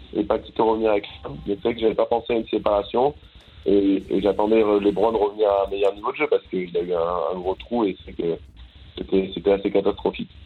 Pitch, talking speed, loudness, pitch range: 100 Hz, 260 wpm, -22 LUFS, 100-110 Hz